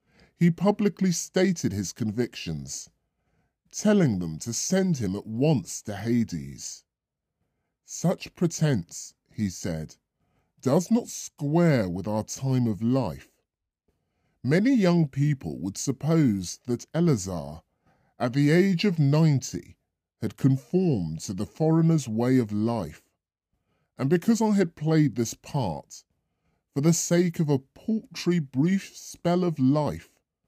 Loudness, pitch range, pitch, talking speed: -26 LUFS, 105-170 Hz, 135 Hz, 125 wpm